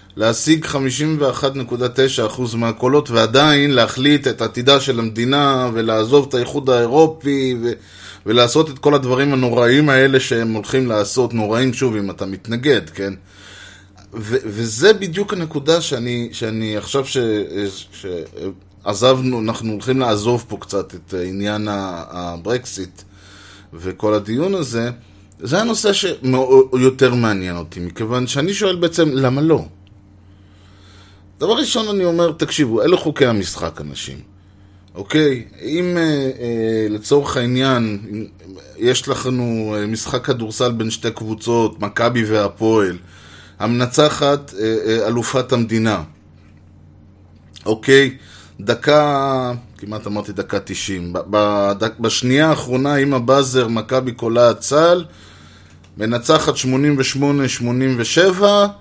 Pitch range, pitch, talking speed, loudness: 100-135 Hz, 115 Hz, 105 wpm, -17 LUFS